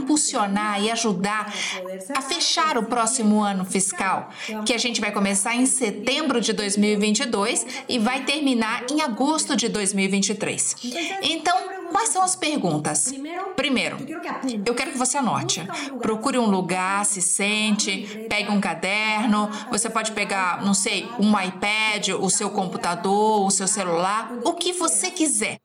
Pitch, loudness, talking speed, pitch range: 220 Hz, -22 LUFS, 145 wpm, 205-270 Hz